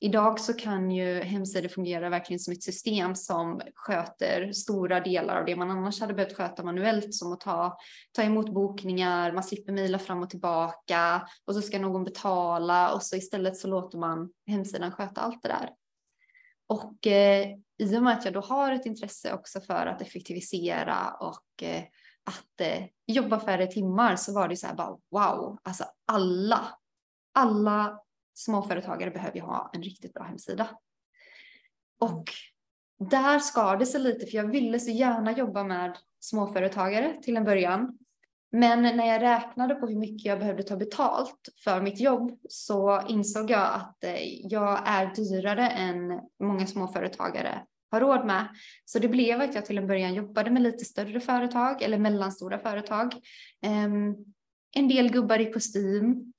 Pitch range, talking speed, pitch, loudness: 185-230 Hz, 165 wpm, 205 Hz, -28 LUFS